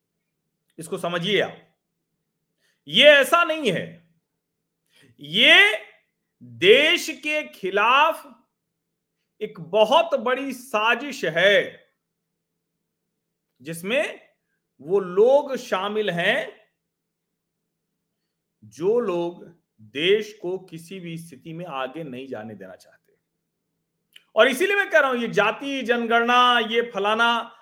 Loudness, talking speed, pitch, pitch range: -20 LUFS, 100 wpm, 215 Hz, 165-275 Hz